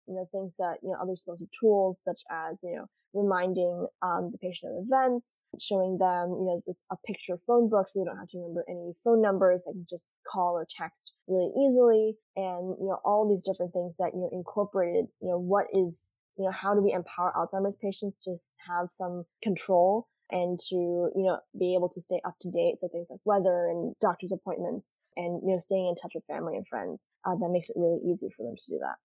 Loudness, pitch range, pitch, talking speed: -30 LUFS, 175-195 Hz, 185 Hz, 235 wpm